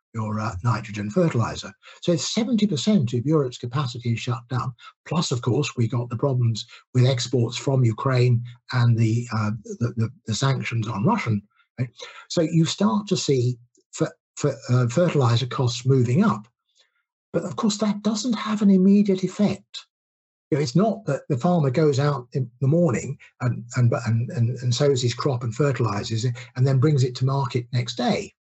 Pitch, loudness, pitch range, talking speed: 130 Hz, -23 LUFS, 120-155 Hz, 185 wpm